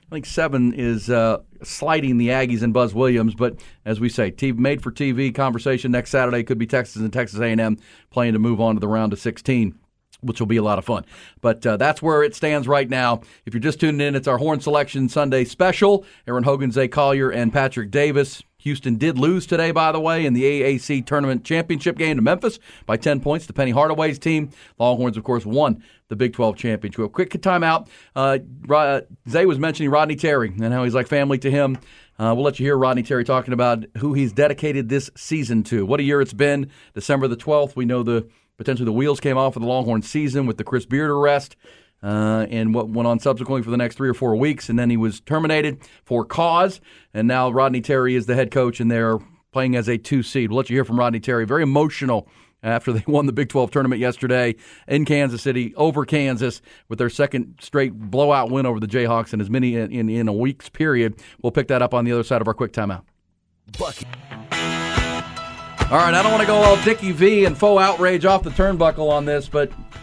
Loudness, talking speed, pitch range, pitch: -20 LUFS, 225 wpm, 115-145 Hz, 130 Hz